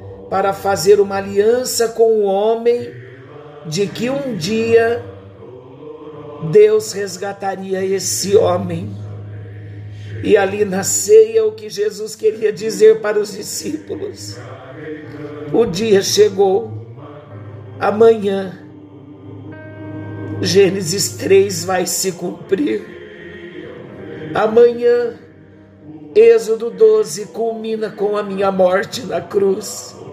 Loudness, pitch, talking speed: -15 LUFS, 195 Hz, 90 wpm